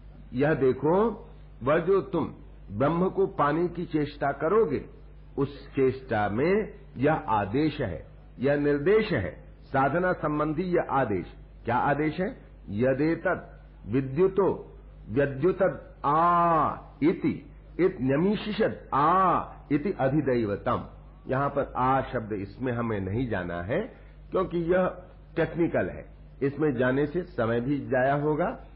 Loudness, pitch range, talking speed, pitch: -27 LUFS, 130-175 Hz, 115 wpm, 145 Hz